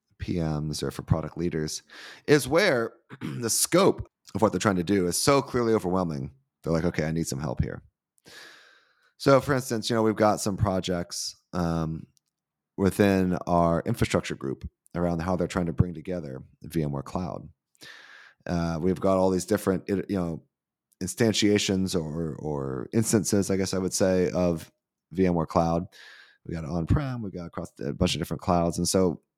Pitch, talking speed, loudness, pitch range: 90 Hz, 170 wpm, -26 LUFS, 80-100 Hz